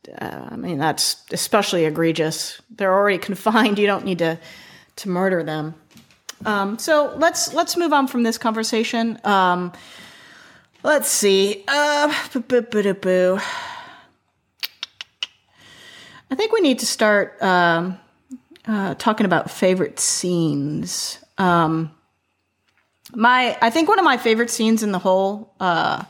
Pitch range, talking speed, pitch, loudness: 180-240 Hz, 125 wpm, 205 Hz, -19 LUFS